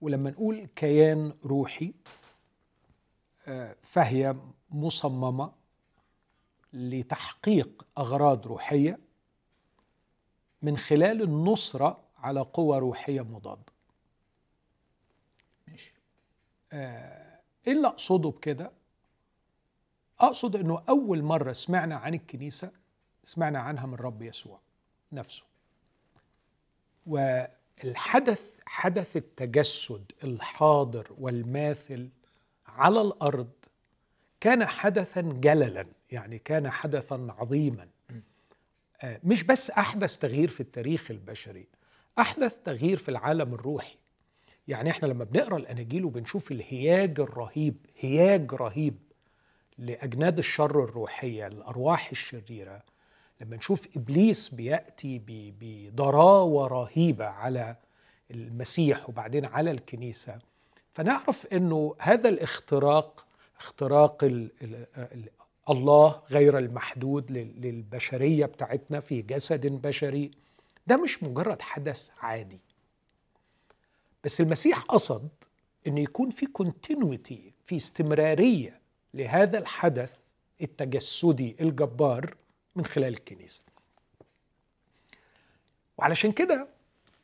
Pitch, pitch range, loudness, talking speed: 145 Hz, 125-165 Hz, -27 LUFS, 85 wpm